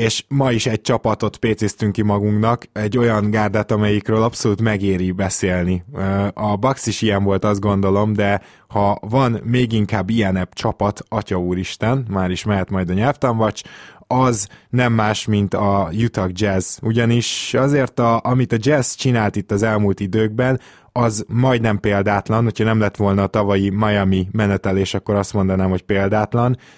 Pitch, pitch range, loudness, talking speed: 105 Hz, 100-115 Hz, -18 LUFS, 160 wpm